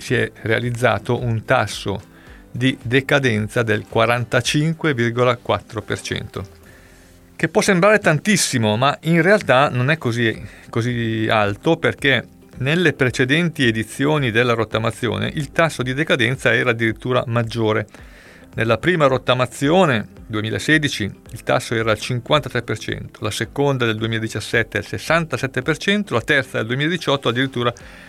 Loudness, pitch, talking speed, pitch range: -19 LUFS, 120 Hz, 115 wpm, 110-140 Hz